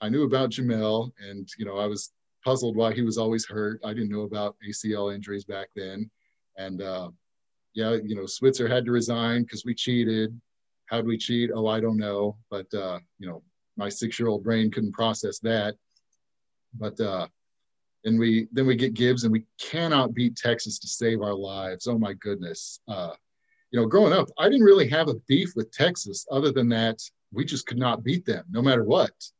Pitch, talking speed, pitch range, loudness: 115 Hz, 200 wpm, 105-120 Hz, -26 LUFS